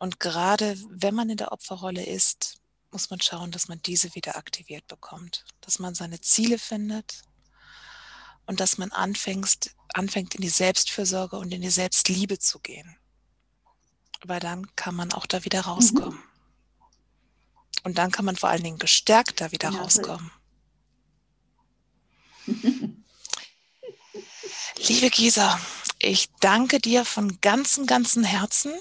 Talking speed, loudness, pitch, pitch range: 135 wpm, -23 LUFS, 195 Hz, 180-225 Hz